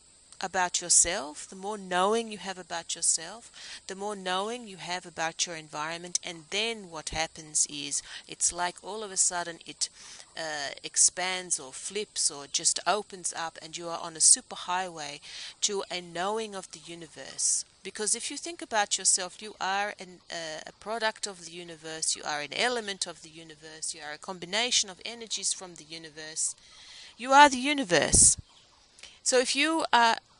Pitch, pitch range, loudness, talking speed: 180 Hz, 165-210 Hz, -27 LUFS, 175 wpm